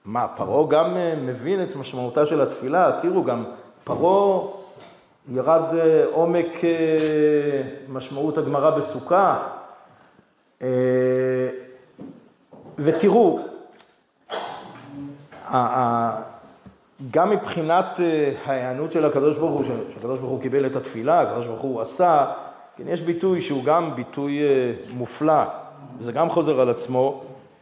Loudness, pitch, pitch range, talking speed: -22 LUFS, 145 Hz, 130-165 Hz, 100 wpm